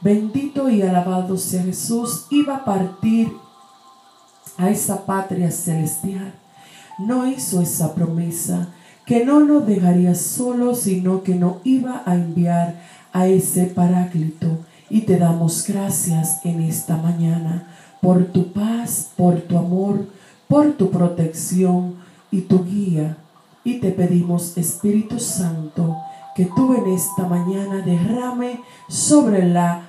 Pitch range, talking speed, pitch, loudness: 170-200 Hz, 125 wpm, 180 Hz, -19 LUFS